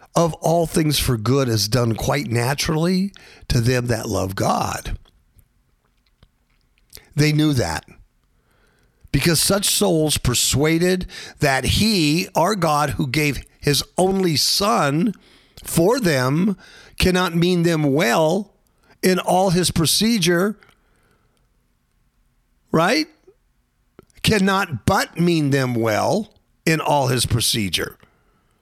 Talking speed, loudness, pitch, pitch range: 105 wpm, -19 LUFS, 155 Hz, 125-180 Hz